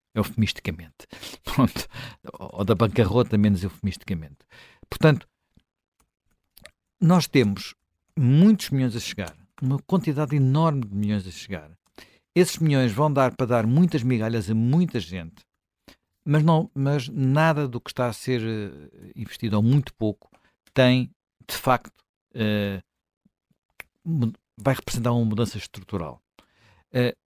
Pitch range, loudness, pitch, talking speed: 105-140 Hz, -23 LUFS, 120 Hz, 120 wpm